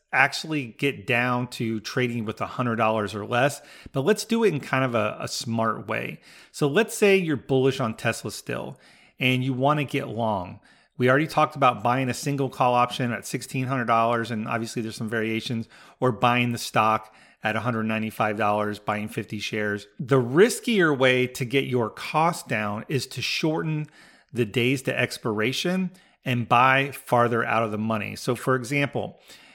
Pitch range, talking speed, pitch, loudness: 110-135 Hz, 190 wpm, 125 Hz, -24 LUFS